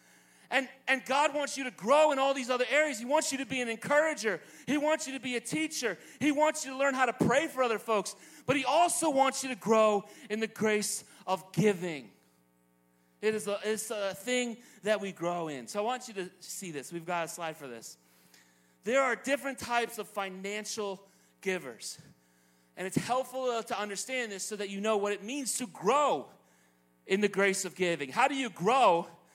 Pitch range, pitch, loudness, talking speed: 180-265 Hz, 215 Hz, -31 LUFS, 210 wpm